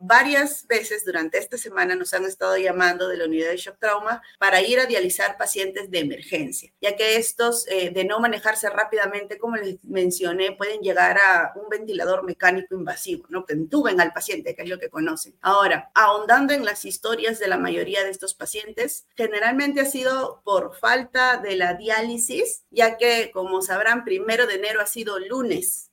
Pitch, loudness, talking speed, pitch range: 215 Hz, -22 LUFS, 185 wpm, 190-255 Hz